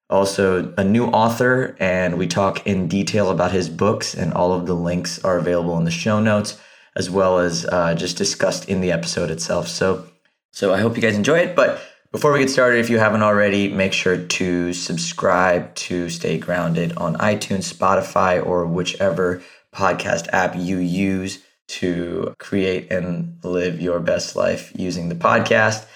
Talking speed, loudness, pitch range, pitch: 175 wpm, -19 LUFS, 90-100 Hz, 90 Hz